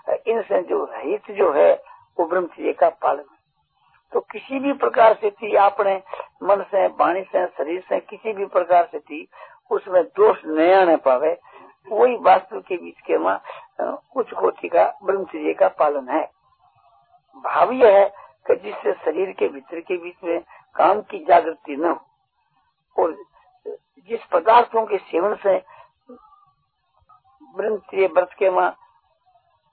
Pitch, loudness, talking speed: 235 Hz, -20 LUFS, 140 wpm